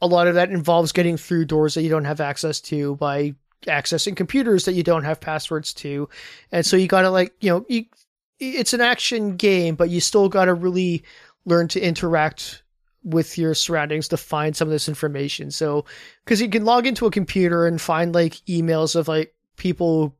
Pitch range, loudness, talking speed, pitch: 155-185 Hz, -20 LUFS, 195 wpm, 170 Hz